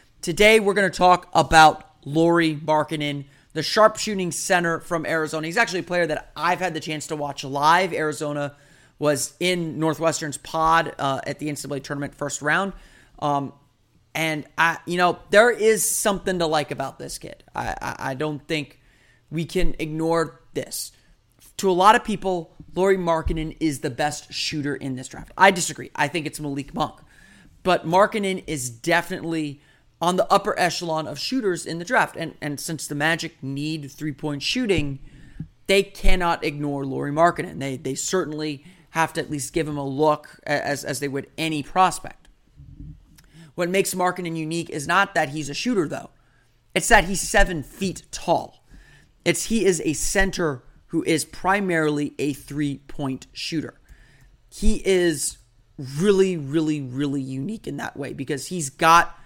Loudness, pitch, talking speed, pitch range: -23 LUFS, 155 Hz, 165 wpm, 145-175 Hz